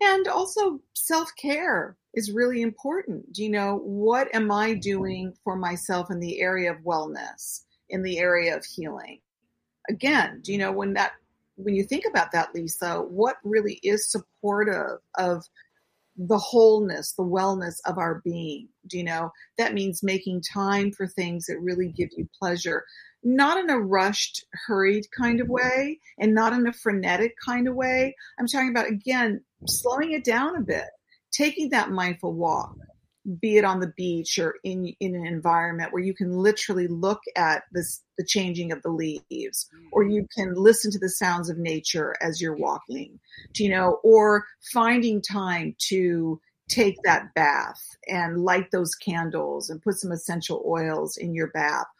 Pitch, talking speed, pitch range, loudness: 195 Hz, 170 wpm, 180-230 Hz, -25 LUFS